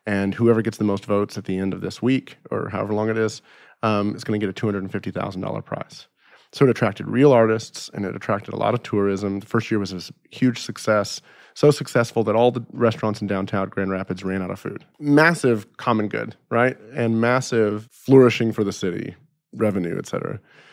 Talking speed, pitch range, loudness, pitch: 205 wpm, 100-120 Hz, -22 LUFS, 110 Hz